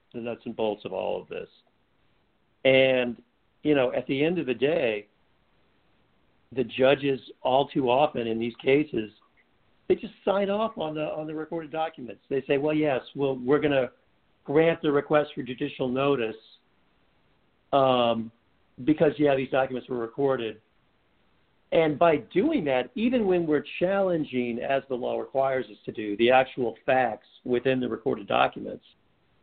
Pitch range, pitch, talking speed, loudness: 125-155 Hz, 135 Hz, 160 wpm, -26 LUFS